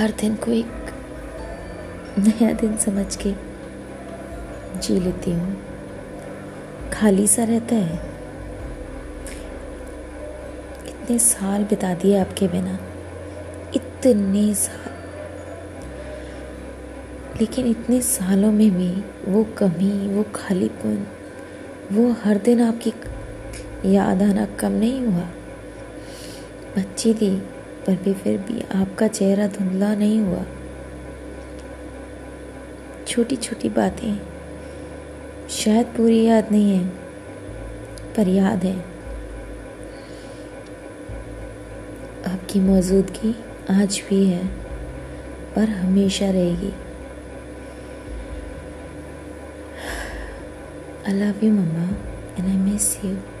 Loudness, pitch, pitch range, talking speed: -21 LUFS, 195 Hz, 175-215 Hz, 85 wpm